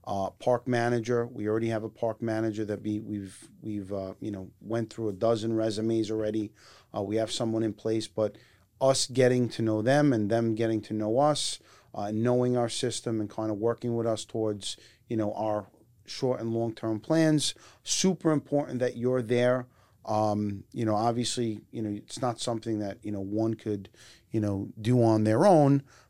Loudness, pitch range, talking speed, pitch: -29 LUFS, 105-120 Hz, 195 wpm, 110 Hz